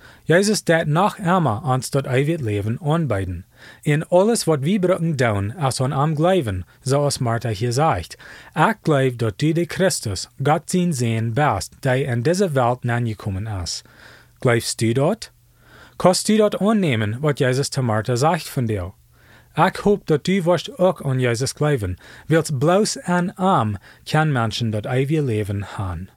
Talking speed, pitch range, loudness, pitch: 165 wpm, 115-165 Hz, -20 LUFS, 135 Hz